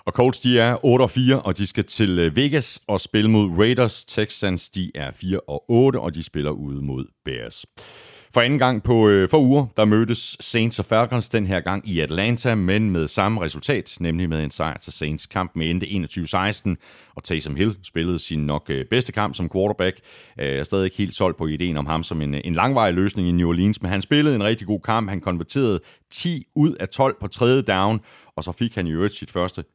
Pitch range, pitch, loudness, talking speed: 85-115 Hz, 100 Hz, -21 LUFS, 220 wpm